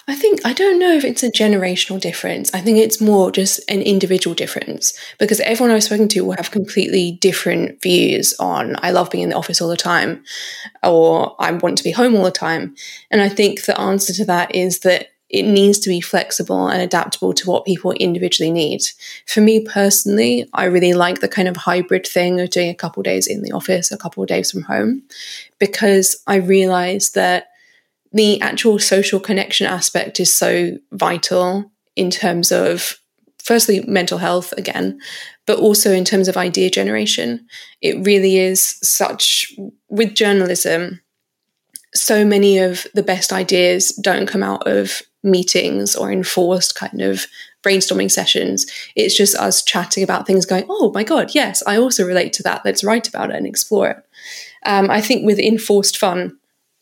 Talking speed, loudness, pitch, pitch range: 180 wpm, -15 LUFS, 195 Hz, 180-215 Hz